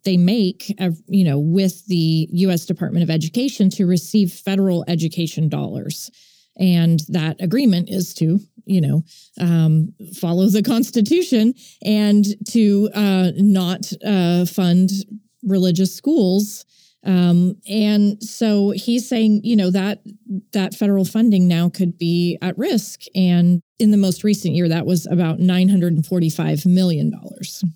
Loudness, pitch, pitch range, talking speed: -18 LUFS, 185 Hz, 175-205 Hz, 135 wpm